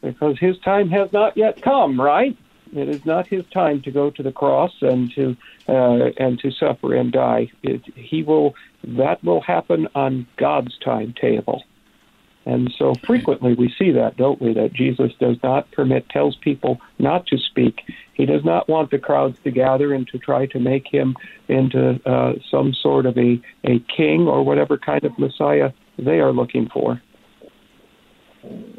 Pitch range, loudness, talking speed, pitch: 115-150 Hz, -19 LUFS, 175 wpm, 130 Hz